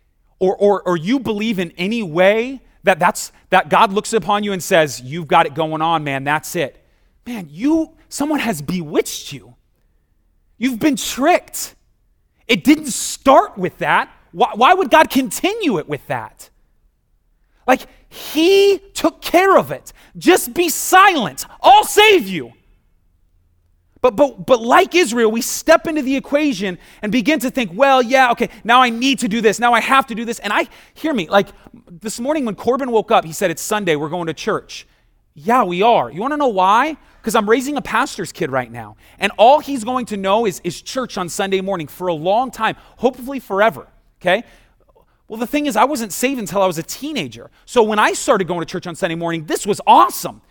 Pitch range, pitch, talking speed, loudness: 180-270 Hz, 225 Hz, 200 wpm, -16 LUFS